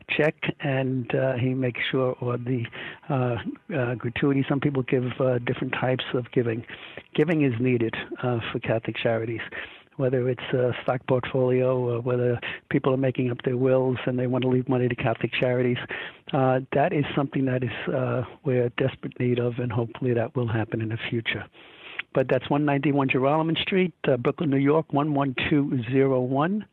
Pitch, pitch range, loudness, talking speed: 130 Hz, 125-140 Hz, -25 LUFS, 175 wpm